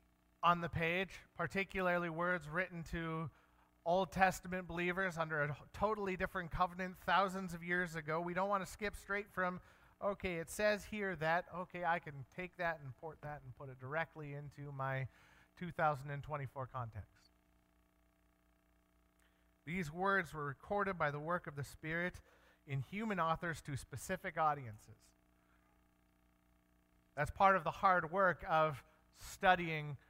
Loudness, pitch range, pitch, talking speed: -39 LUFS, 130-180 Hz, 160 Hz, 140 wpm